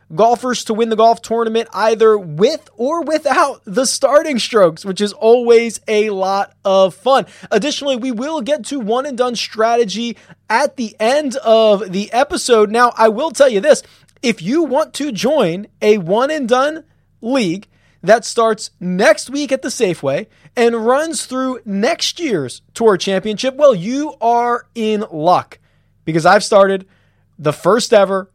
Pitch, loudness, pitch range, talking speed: 230 Hz, -15 LUFS, 205-265 Hz, 160 wpm